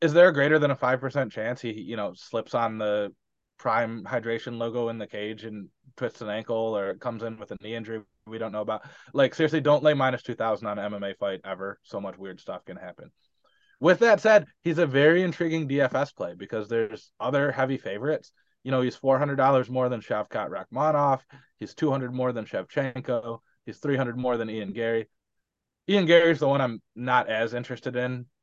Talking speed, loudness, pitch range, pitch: 200 wpm, -26 LUFS, 110-140 Hz, 125 Hz